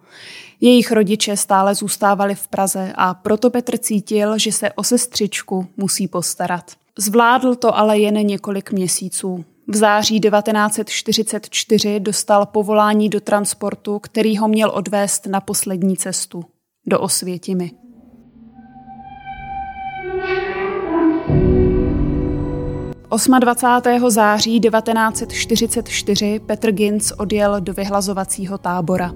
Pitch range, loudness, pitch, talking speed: 195-230 Hz, -17 LUFS, 210 Hz, 95 wpm